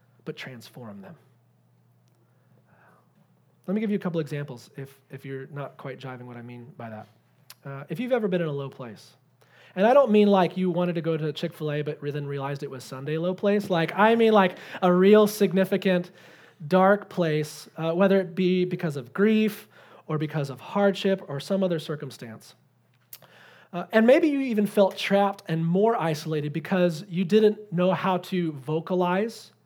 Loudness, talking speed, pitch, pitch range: -24 LUFS, 185 wpm, 170 Hz, 140-195 Hz